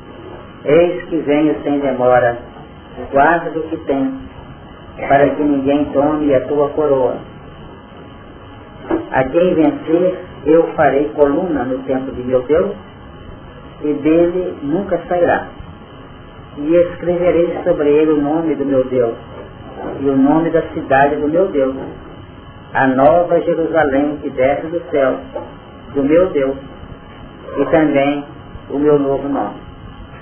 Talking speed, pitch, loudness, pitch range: 125 wpm, 145 Hz, -15 LUFS, 135-165 Hz